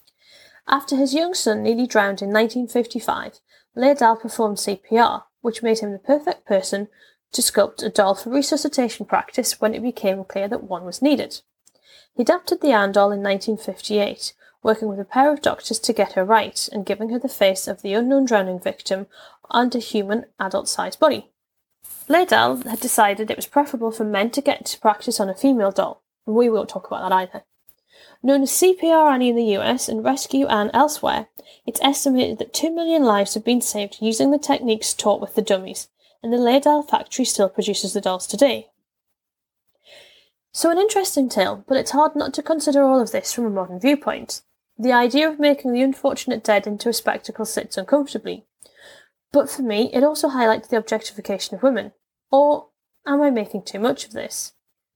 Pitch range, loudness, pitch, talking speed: 210-280 Hz, -20 LUFS, 235 Hz, 185 wpm